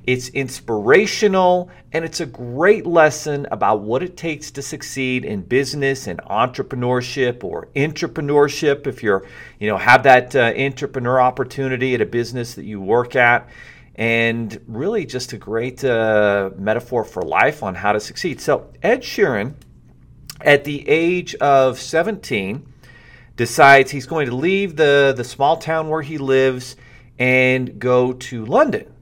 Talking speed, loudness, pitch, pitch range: 150 wpm, -18 LUFS, 130 Hz, 120-145 Hz